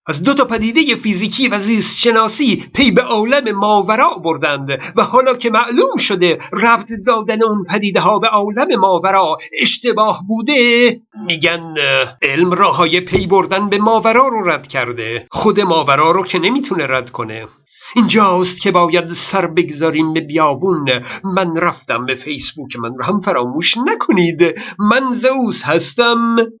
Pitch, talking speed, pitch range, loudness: 200 Hz, 145 wpm, 170-230 Hz, -13 LUFS